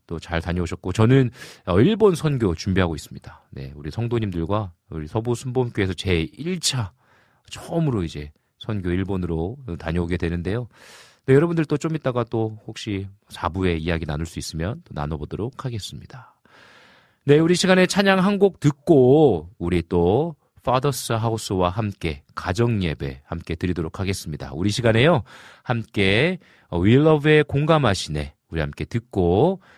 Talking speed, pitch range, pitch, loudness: 335 characters per minute, 85-130 Hz, 105 Hz, -22 LUFS